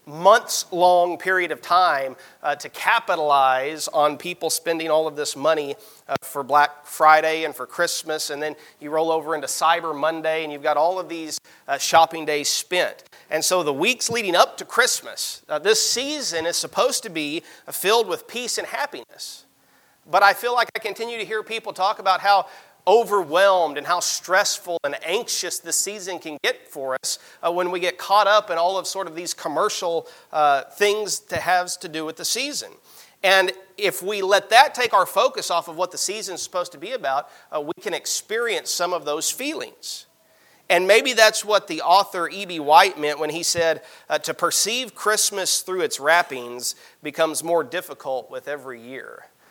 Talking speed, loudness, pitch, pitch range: 190 wpm, -21 LUFS, 175 Hz, 155-205 Hz